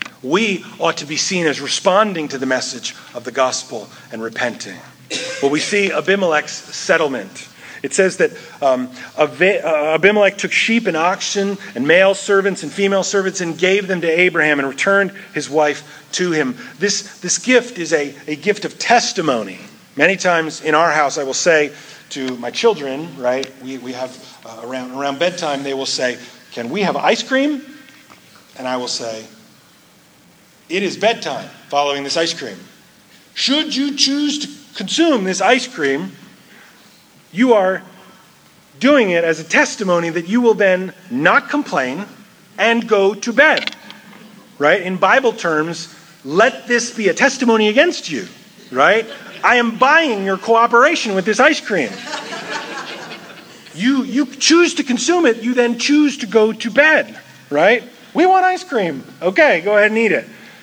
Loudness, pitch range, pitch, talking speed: -16 LUFS, 150-240 Hz, 195 Hz, 160 wpm